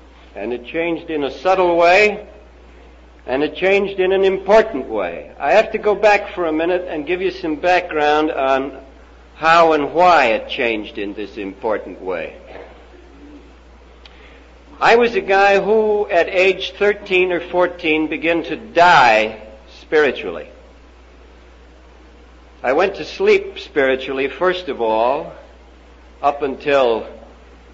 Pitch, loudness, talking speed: 155 Hz, -16 LUFS, 130 wpm